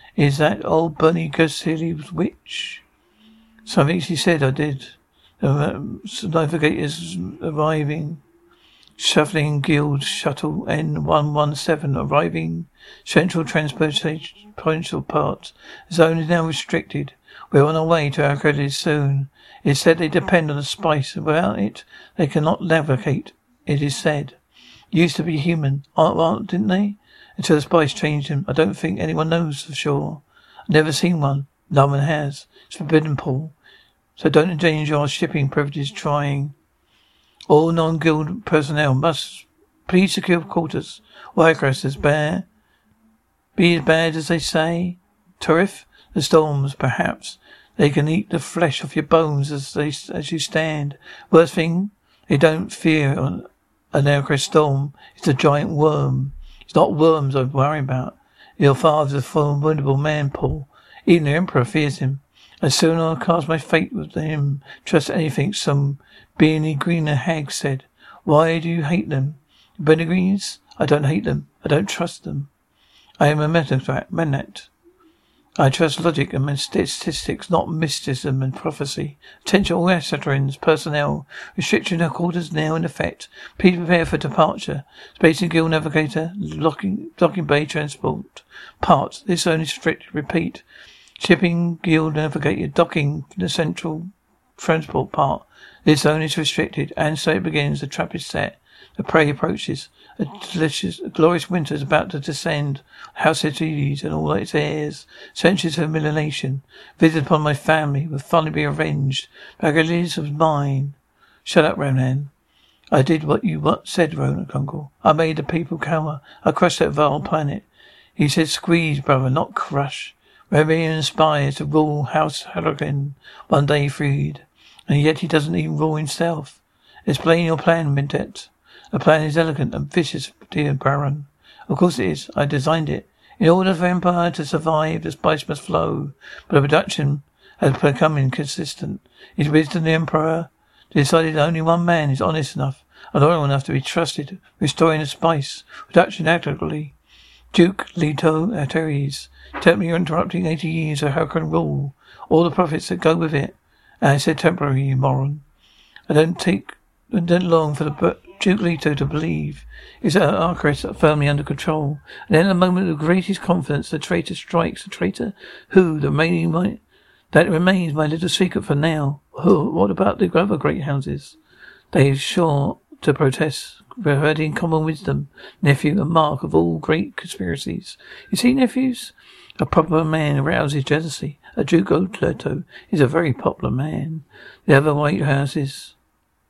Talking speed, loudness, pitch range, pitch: 160 wpm, -20 LUFS, 145-170 Hz, 155 Hz